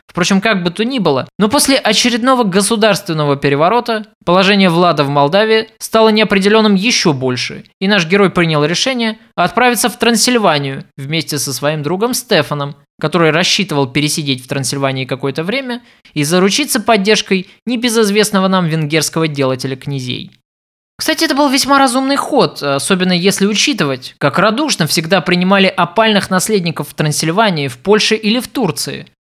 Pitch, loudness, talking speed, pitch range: 190 Hz, -13 LUFS, 140 wpm, 150-225 Hz